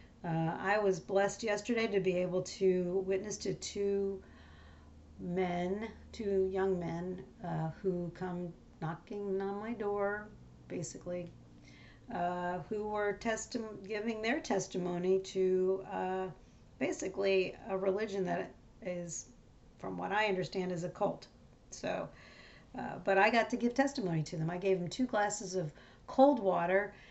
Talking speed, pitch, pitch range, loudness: 140 wpm, 190 Hz, 175-205 Hz, -35 LUFS